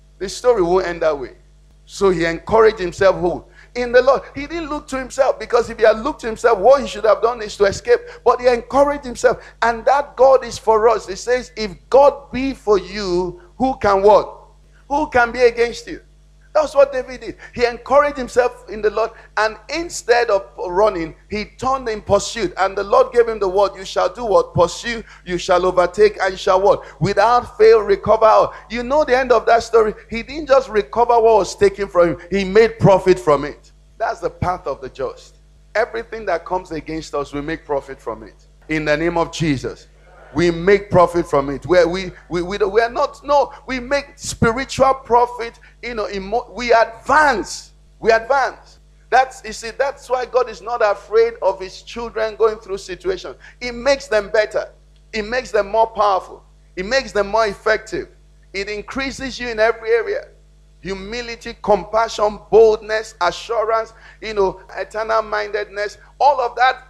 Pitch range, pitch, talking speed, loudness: 195-255 Hz, 225 Hz, 190 wpm, -17 LUFS